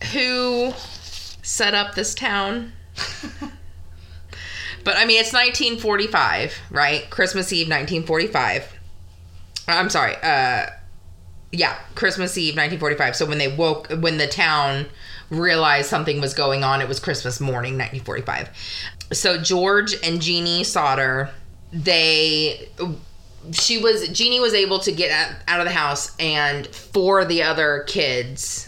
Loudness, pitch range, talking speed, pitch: -19 LUFS, 125-185 Hz, 125 wpm, 155 Hz